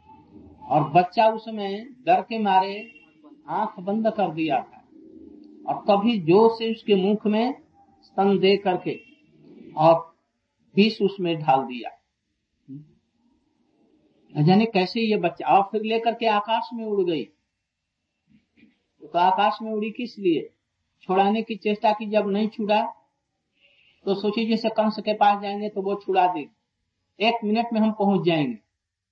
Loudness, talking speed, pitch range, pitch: -23 LUFS, 140 wpm, 185-225 Hz, 210 Hz